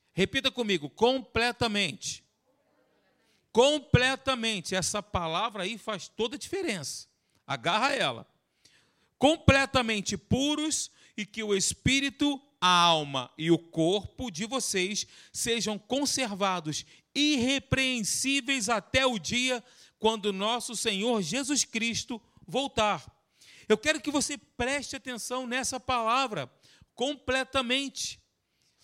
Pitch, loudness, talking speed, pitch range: 240 Hz, -28 LUFS, 100 wpm, 205-265 Hz